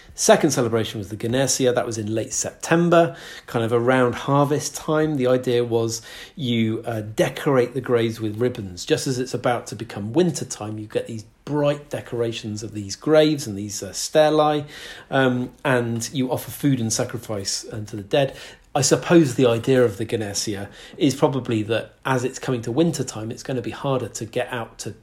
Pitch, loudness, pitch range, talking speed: 125 Hz, -22 LUFS, 115-135 Hz, 190 wpm